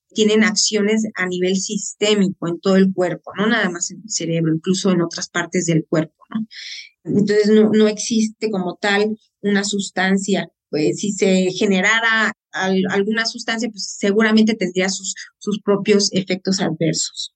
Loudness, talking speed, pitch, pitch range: -18 LUFS, 150 wpm, 195 Hz, 185-215 Hz